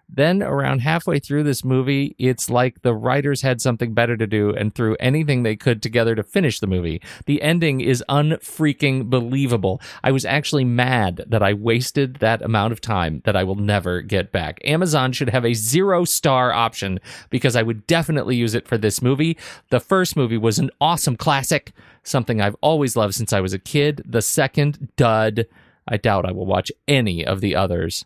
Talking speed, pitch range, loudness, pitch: 195 wpm, 110-140 Hz, -20 LUFS, 125 Hz